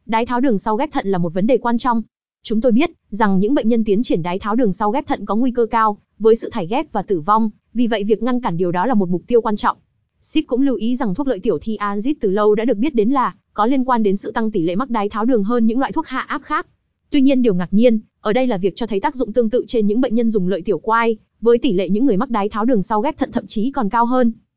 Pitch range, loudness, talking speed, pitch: 210-255 Hz, -18 LUFS, 310 wpm, 230 Hz